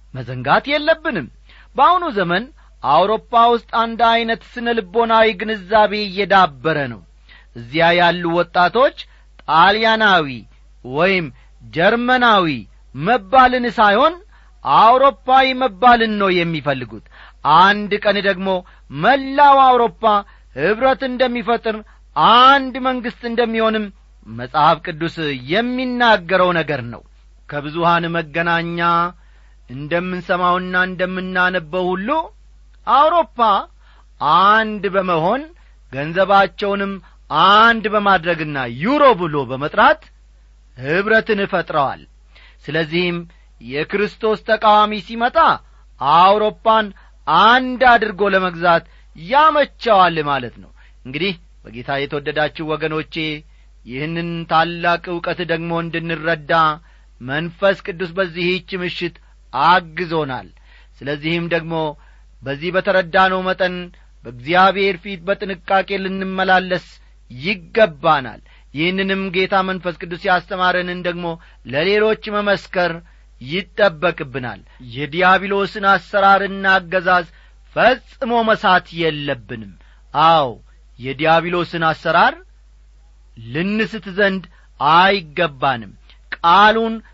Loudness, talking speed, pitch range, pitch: -16 LUFS, 80 wpm, 160-215 Hz, 185 Hz